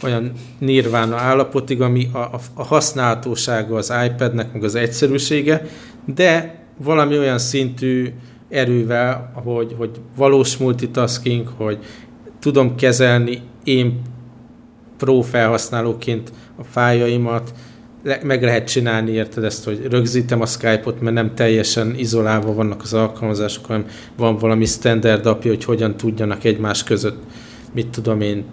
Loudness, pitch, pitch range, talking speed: -18 LUFS, 120 Hz, 115-125 Hz, 125 wpm